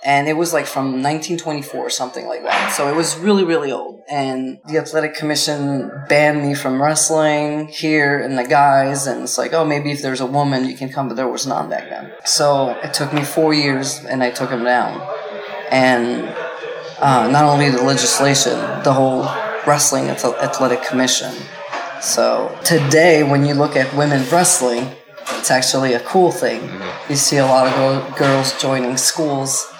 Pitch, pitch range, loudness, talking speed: 145 Hz, 130-155 Hz, -16 LUFS, 180 wpm